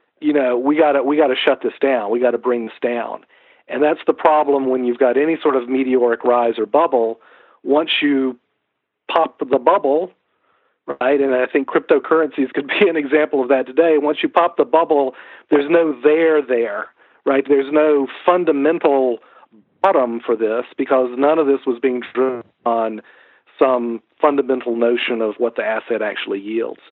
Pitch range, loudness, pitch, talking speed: 125-150 Hz, -17 LUFS, 135 Hz, 180 wpm